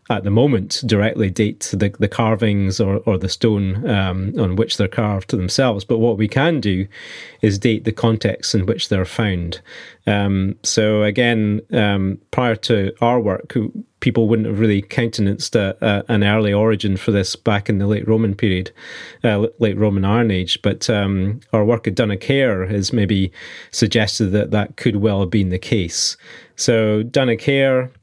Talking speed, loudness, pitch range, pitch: 175 wpm, -18 LUFS, 100-115 Hz, 110 Hz